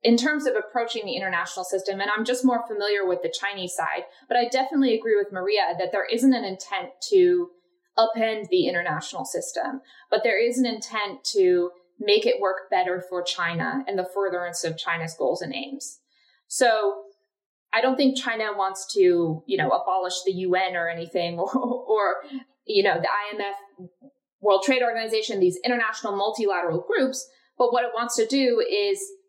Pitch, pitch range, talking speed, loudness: 215 Hz, 185-260 Hz, 175 wpm, -24 LUFS